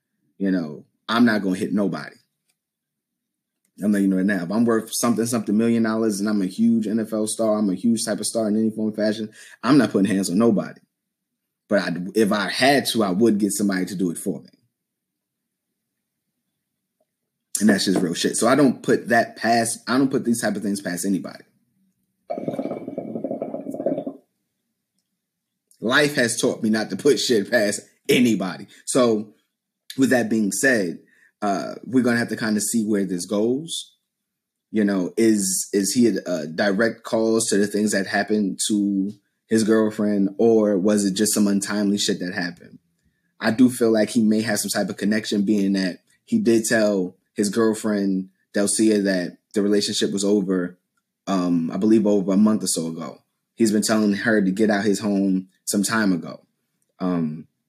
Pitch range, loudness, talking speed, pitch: 100-115 Hz, -21 LUFS, 185 wpm, 105 Hz